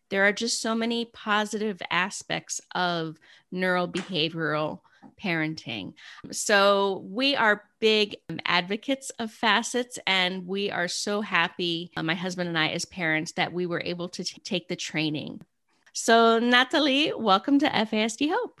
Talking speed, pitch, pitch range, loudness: 145 wpm, 195 Hz, 175-225 Hz, -25 LUFS